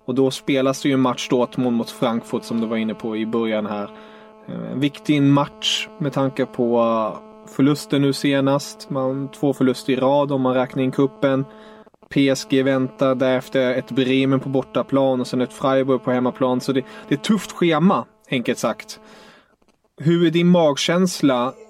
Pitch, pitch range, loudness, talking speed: 135 Hz, 130-150 Hz, -20 LUFS, 175 wpm